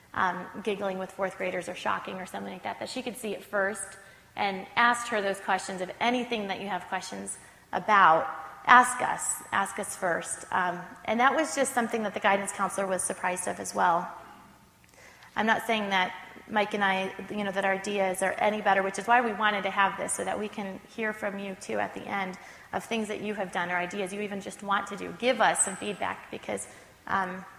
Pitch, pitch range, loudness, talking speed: 200 Hz, 190-215 Hz, -28 LUFS, 225 wpm